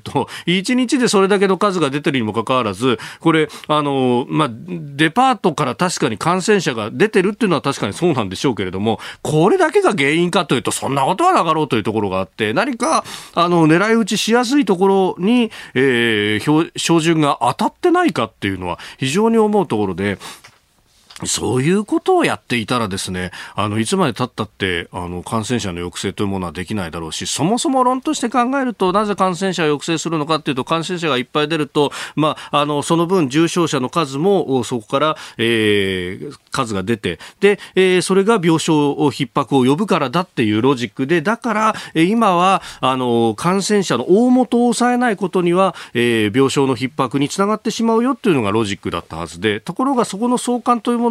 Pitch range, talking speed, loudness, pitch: 120-200 Hz, 405 characters per minute, -17 LUFS, 155 Hz